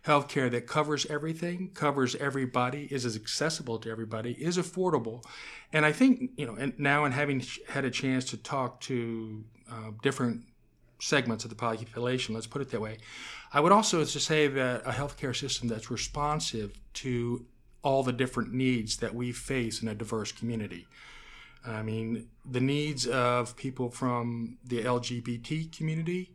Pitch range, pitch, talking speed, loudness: 115-145 Hz, 125 Hz, 160 wpm, -31 LUFS